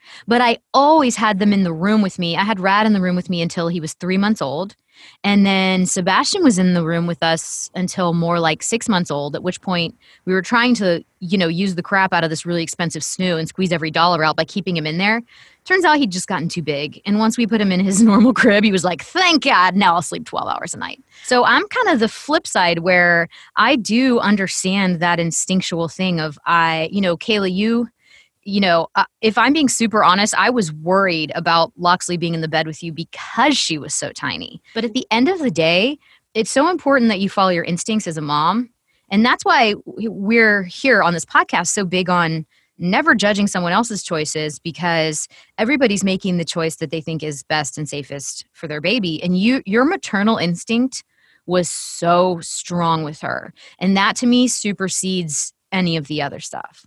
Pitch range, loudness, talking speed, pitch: 170-225 Hz, -17 LUFS, 220 wpm, 185 Hz